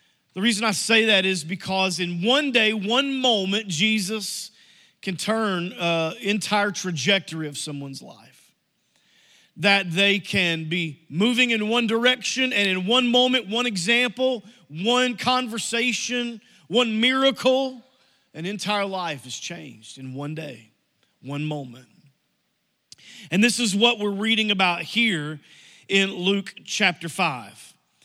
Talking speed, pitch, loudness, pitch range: 130 wpm, 200 Hz, -22 LUFS, 170-235 Hz